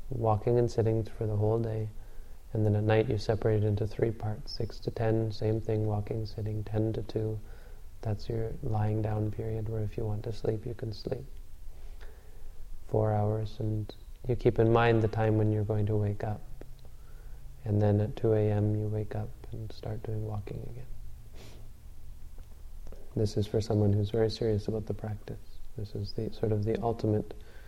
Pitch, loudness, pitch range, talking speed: 110 Hz, -31 LUFS, 105-110 Hz, 185 wpm